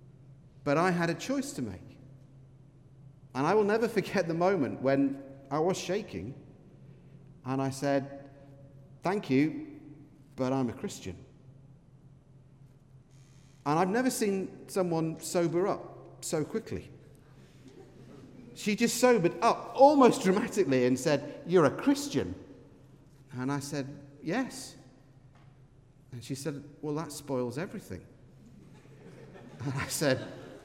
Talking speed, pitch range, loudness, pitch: 120 wpm, 135-170 Hz, -30 LUFS, 140 Hz